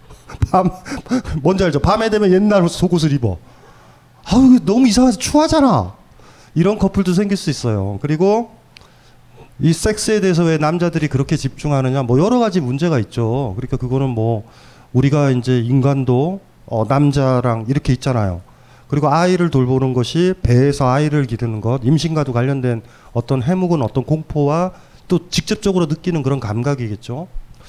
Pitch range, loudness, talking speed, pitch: 125-180 Hz, -16 LUFS, 330 characters per minute, 145 Hz